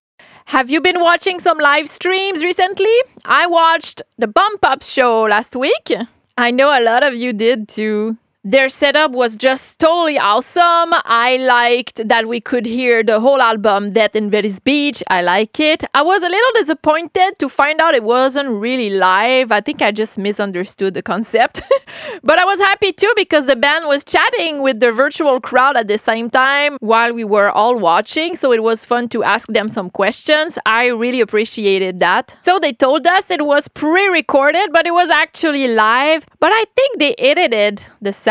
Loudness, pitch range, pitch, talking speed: -14 LUFS, 225-320 Hz, 265 Hz, 190 wpm